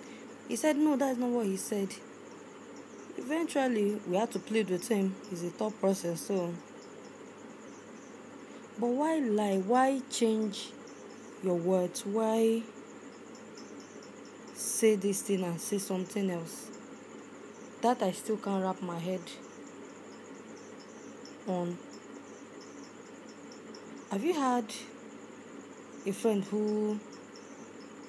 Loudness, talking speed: -32 LUFS, 105 wpm